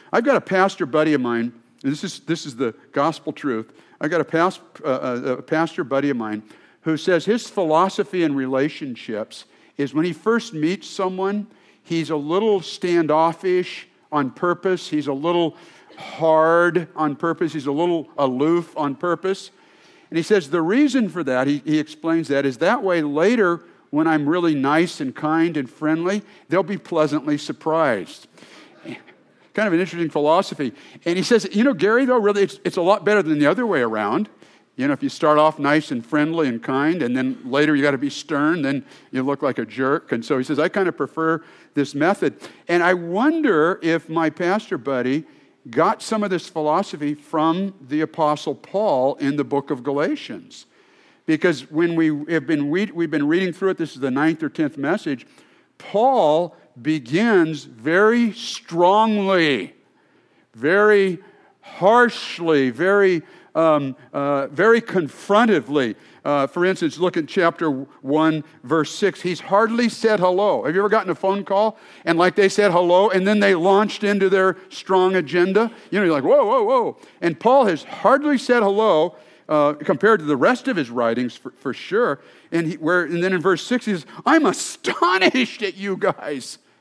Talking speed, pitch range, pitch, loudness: 180 wpm, 150-195 Hz, 170 Hz, -20 LUFS